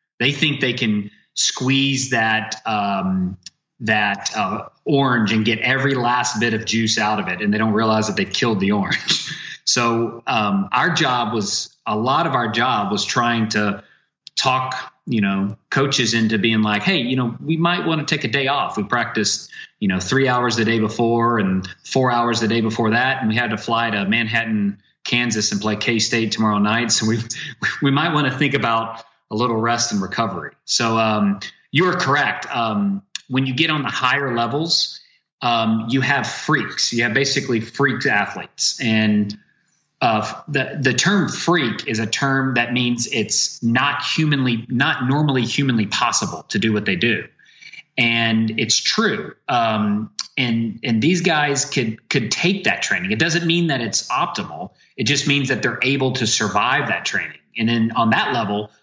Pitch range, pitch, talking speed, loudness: 110-135 Hz, 115 Hz, 185 wpm, -19 LUFS